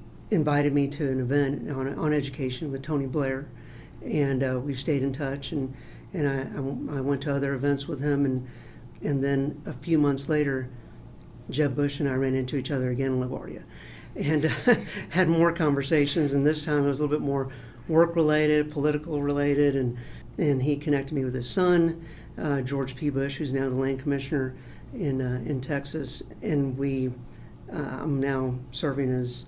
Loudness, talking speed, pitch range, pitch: -27 LUFS, 190 wpm, 130-150 Hz, 140 Hz